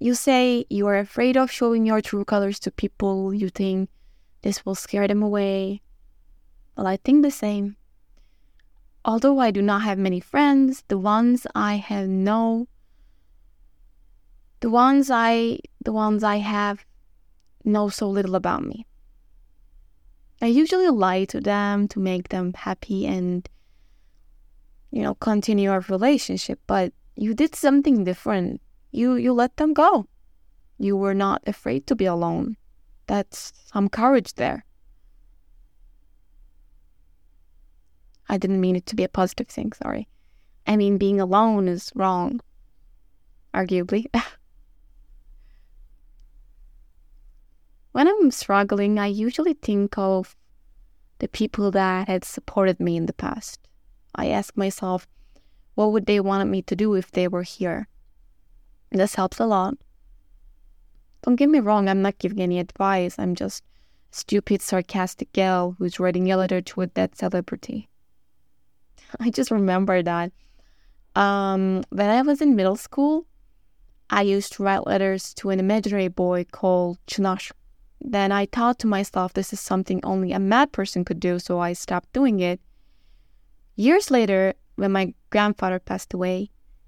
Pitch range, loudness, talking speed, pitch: 175-215 Hz, -22 LUFS, 140 wpm, 195 Hz